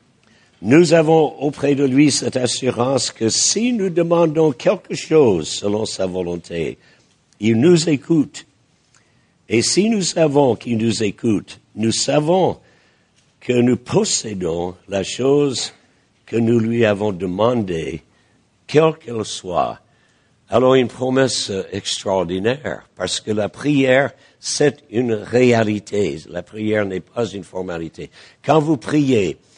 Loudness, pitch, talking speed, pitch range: -18 LUFS, 125 Hz, 125 wpm, 105-145 Hz